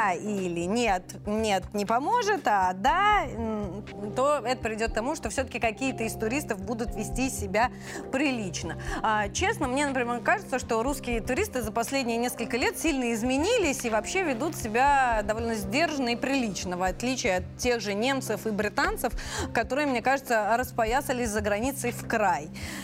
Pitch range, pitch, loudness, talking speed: 220-275 Hz, 240 Hz, -27 LUFS, 155 wpm